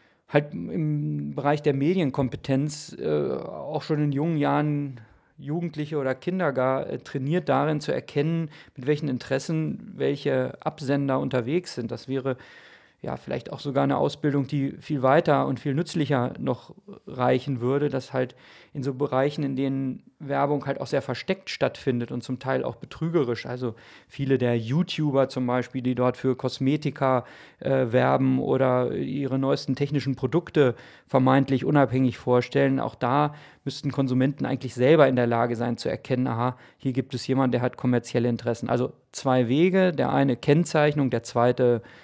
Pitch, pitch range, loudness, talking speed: 135 Hz, 125-145 Hz, -25 LUFS, 160 wpm